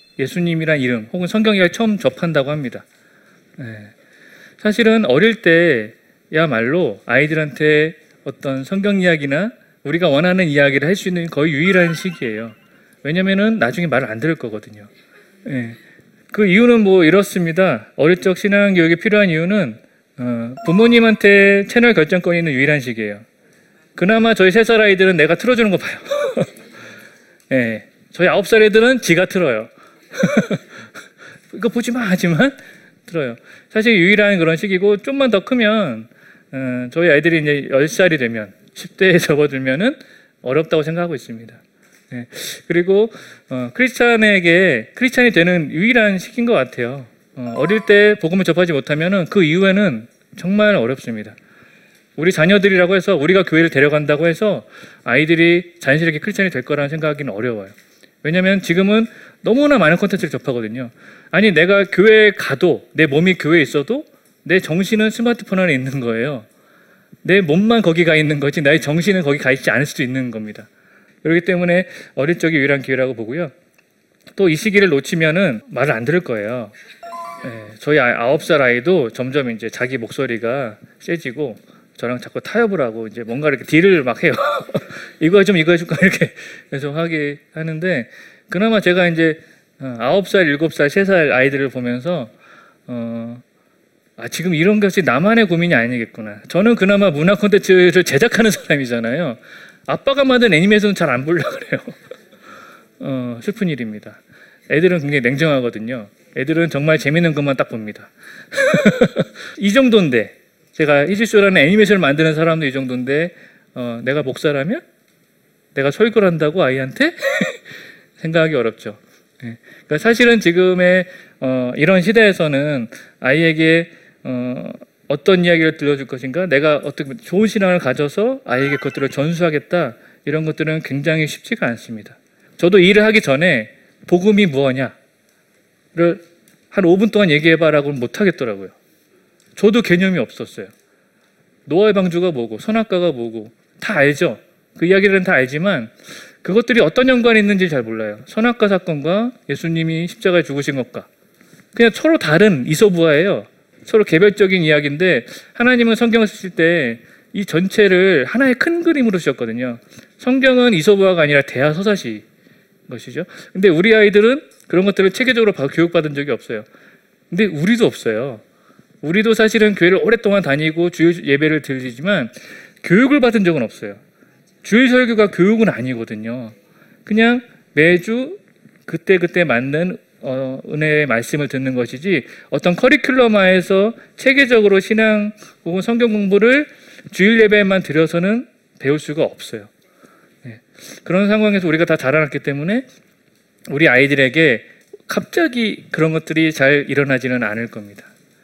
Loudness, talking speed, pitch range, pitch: -15 LUFS, 335 characters per minute, 140-210 Hz, 175 Hz